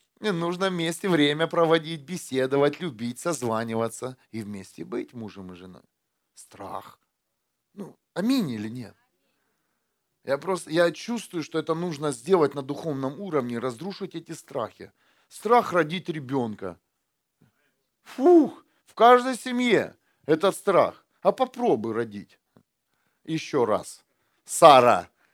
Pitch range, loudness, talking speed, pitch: 125-190 Hz, -24 LUFS, 115 wpm, 160 Hz